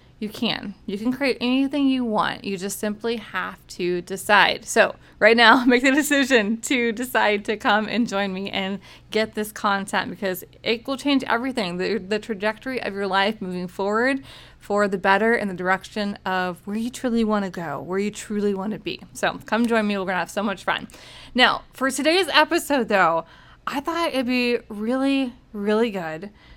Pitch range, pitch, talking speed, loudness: 200-245 Hz, 215 Hz, 195 wpm, -22 LUFS